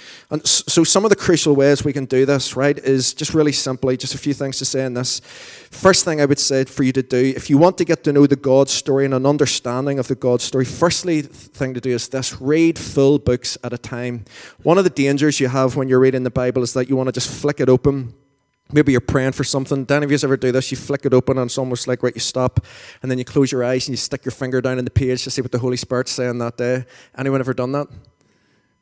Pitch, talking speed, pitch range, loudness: 135 Hz, 275 wpm, 125-140 Hz, -18 LUFS